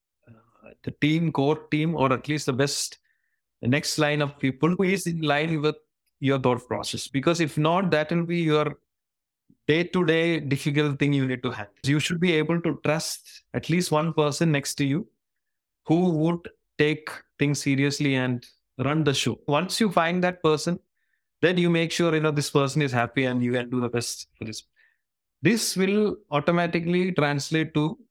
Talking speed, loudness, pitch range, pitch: 185 wpm, -24 LUFS, 135-165 Hz, 150 Hz